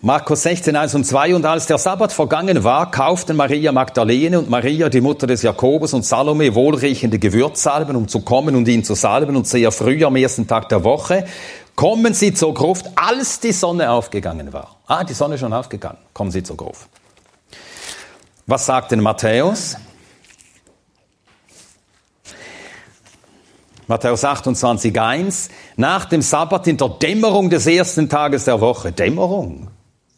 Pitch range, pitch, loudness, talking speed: 120-160 Hz, 140 Hz, -16 LUFS, 155 wpm